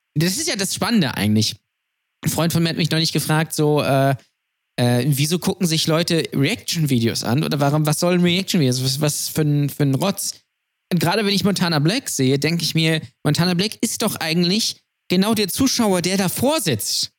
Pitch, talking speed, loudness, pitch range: 160 Hz, 200 wpm, -19 LUFS, 145-185 Hz